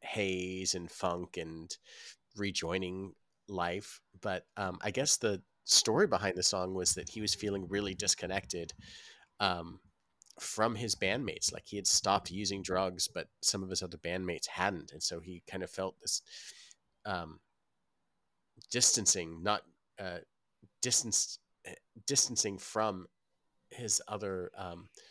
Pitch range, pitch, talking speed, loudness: 90-100 Hz, 95 Hz, 135 wpm, -33 LUFS